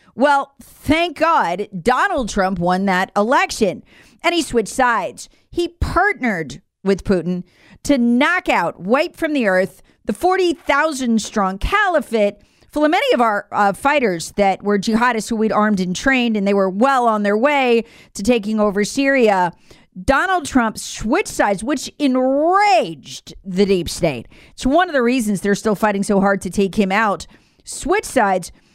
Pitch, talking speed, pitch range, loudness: 230 Hz, 165 wpm, 200-285 Hz, -17 LUFS